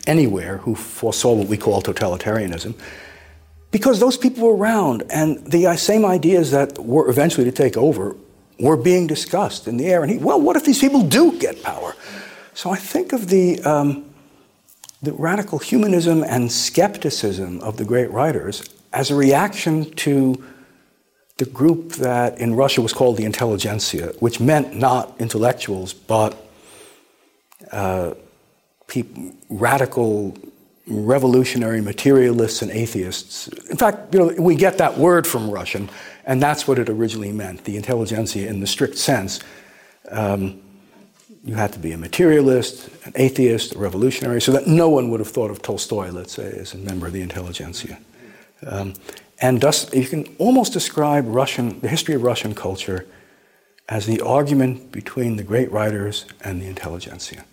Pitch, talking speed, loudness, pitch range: 125 Hz, 155 wpm, -19 LUFS, 105-155 Hz